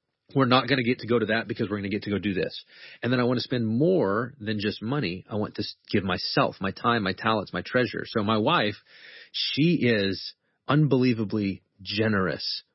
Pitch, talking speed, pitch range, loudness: 110 Hz, 215 wpm, 100-125 Hz, -26 LUFS